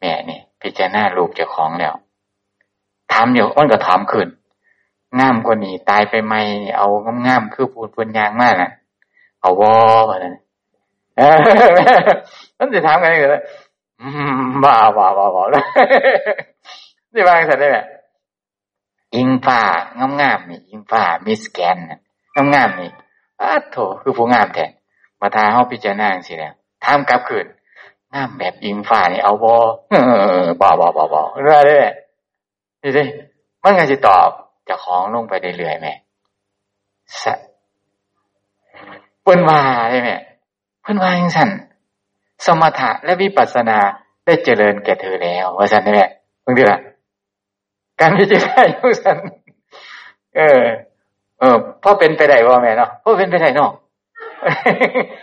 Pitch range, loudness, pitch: 100-145 Hz, -13 LUFS, 115 Hz